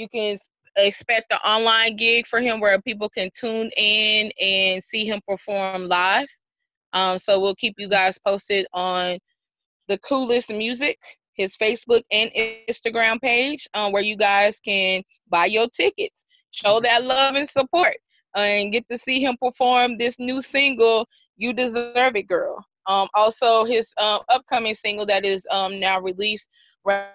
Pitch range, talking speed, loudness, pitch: 200-245 Hz, 160 wpm, -20 LUFS, 220 Hz